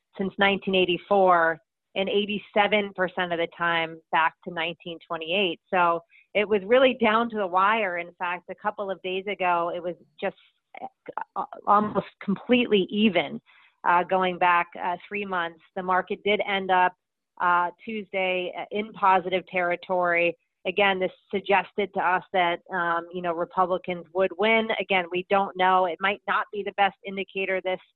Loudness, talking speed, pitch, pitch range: -25 LUFS, 150 wpm, 185 Hz, 175-200 Hz